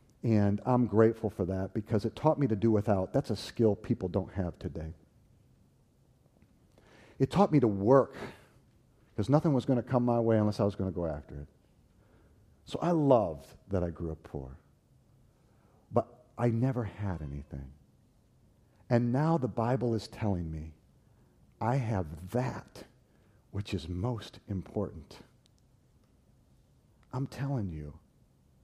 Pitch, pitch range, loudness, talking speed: 110 Hz, 90-120 Hz, -31 LUFS, 145 wpm